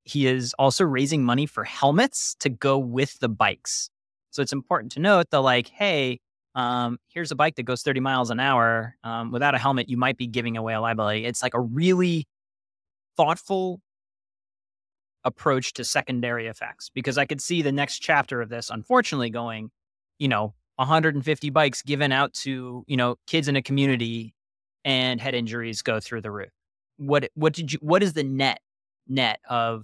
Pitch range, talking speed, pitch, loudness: 120-150 Hz, 185 wpm, 135 Hz, -24 LUFS